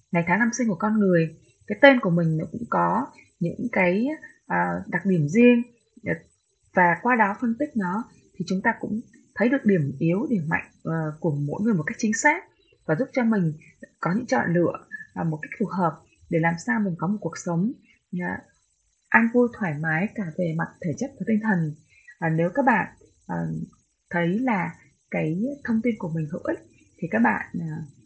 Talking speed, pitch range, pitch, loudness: 190 wpm, 165-235 Hz, 190 Hz, -24 LUFS